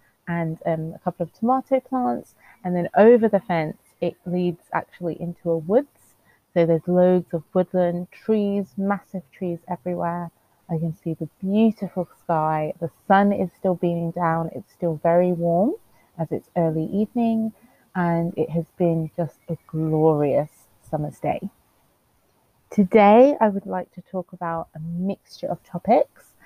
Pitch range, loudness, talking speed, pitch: 165-195 Hz, -23 LUFS, 150 wpm, 175 Hz